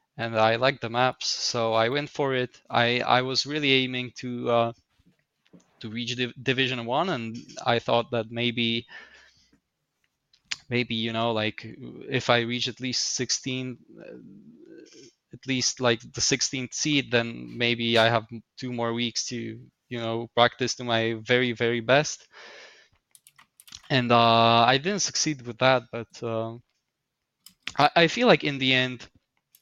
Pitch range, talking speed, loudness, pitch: 115-130 Hz, 150 wpm, -25 LUFS, 120 Hz